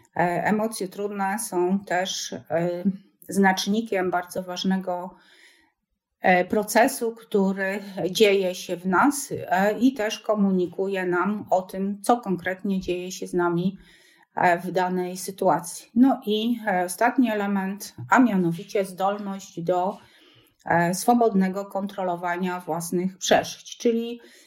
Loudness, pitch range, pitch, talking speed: -24 LUFS, 180-205 Hz, 190 Hz, 100 wpm